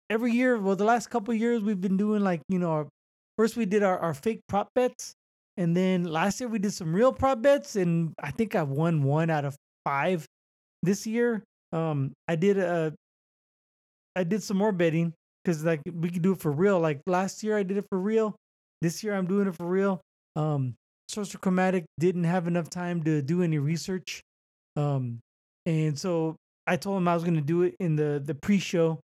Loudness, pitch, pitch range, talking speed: -27 LUFS, 180 Hz, 160-205 Hz, 215 wpm